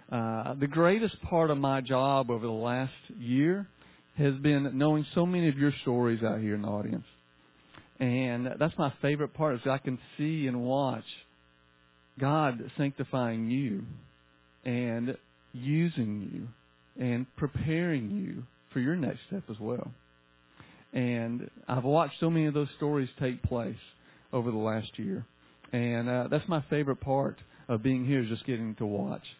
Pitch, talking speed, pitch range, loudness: 125 Hz, 165 wpm, 110-145 Hz, -31 LUFS